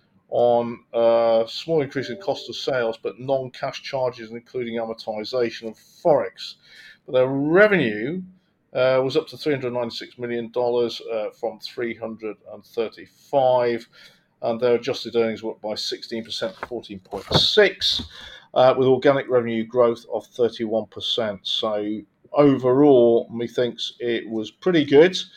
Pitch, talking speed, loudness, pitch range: 120 Hz, 130 wpm, -22 LUFS, 115-135 Hz